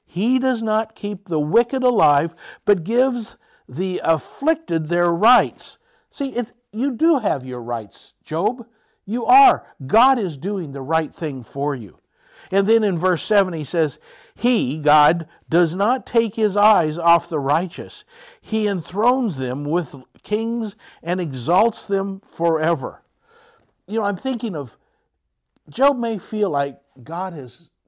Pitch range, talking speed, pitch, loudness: 160-230 Hz, 145 wpm, 195 Hz, -20 LUFS